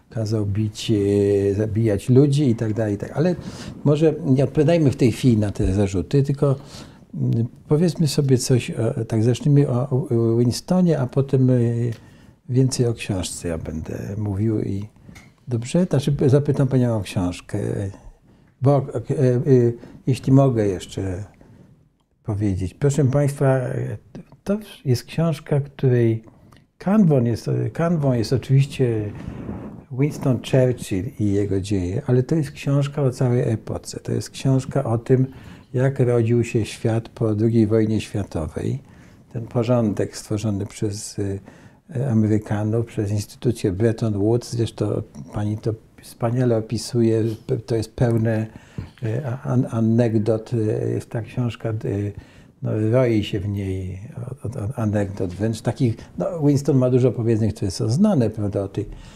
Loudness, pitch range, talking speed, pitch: -21 LUFS, 110-135 Hz, 125 wpm, 120 Hz